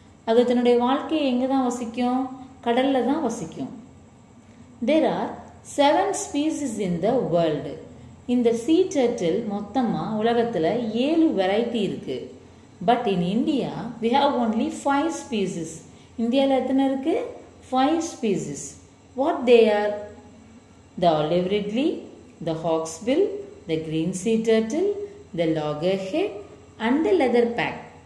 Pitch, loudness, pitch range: 240 Hz, -23 LUFS, 205-280 Hz